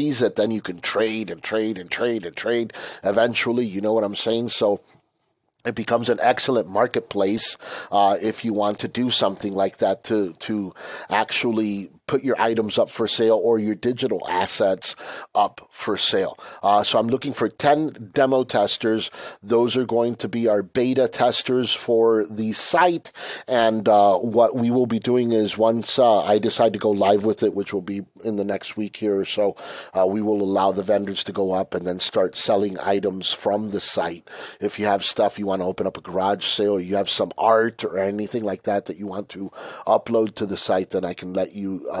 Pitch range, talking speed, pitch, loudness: 100-115 Hz, 205 wpm, 110 Hz, -22 LUFS